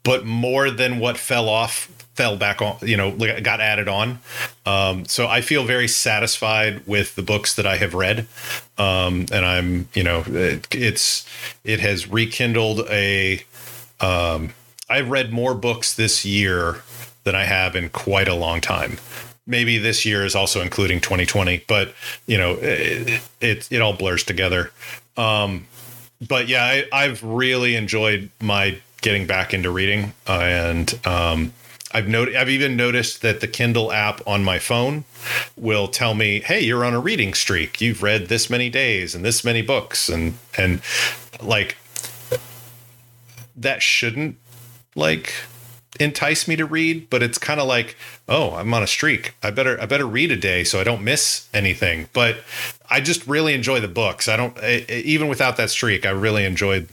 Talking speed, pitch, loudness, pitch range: 175 wpm, 115 Hz, -19 LUFS, 100-125 Hz